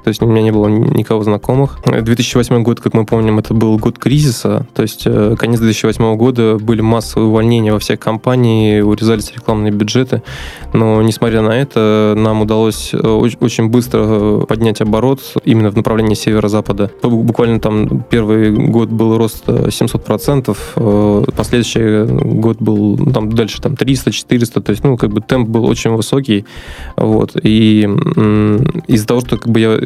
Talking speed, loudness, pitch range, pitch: 155 wpm, -12 LUFS, 110-120 Hz, 110 Hz